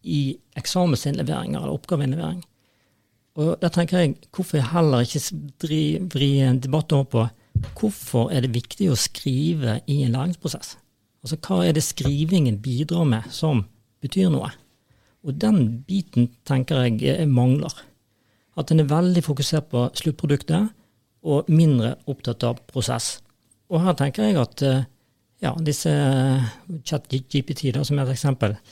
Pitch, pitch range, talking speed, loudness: 140 Hz, 125-160 Hz, 135 wpm, -22 LUFS